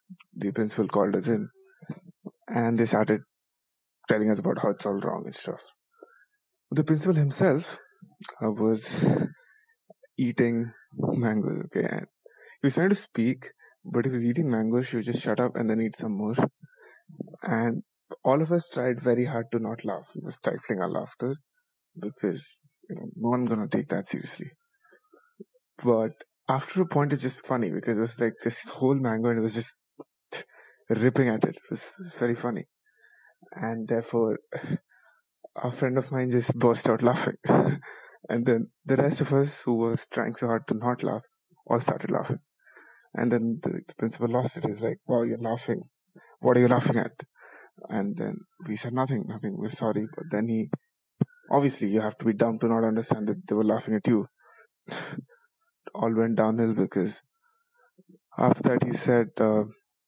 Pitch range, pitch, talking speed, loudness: 115-170 Hz, 125 Hz, 175 wpm, -27 LUFS